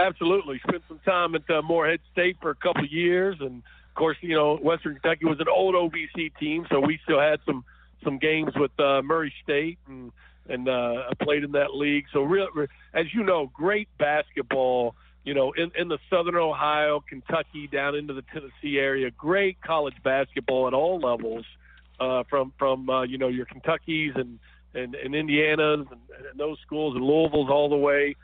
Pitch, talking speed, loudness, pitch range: 150 Hz, 195 wpm, -25 LUFS, 135-165 Hz